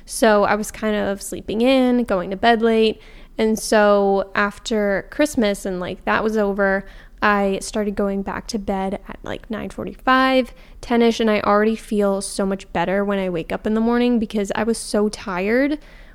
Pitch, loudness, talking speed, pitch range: 210 Hz, -20 LUFS, 190 wpm, 195-230 Hz